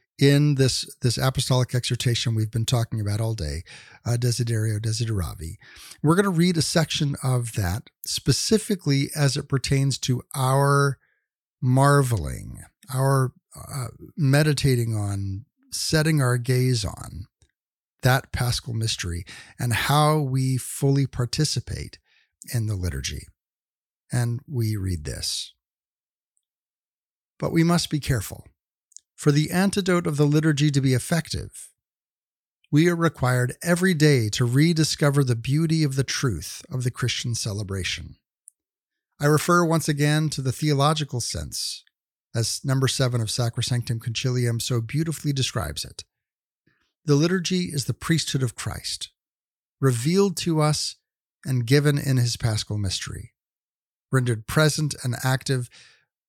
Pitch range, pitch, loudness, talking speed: 115-150 Hz, 130 Hz, -23 LUFS, 130 wpm